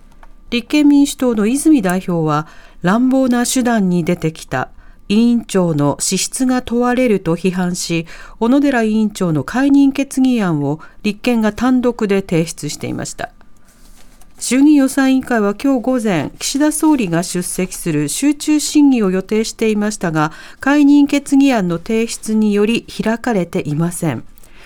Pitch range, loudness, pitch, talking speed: 180-260 Hz, -15 LUFS, 220 Hz, 285 characters per minute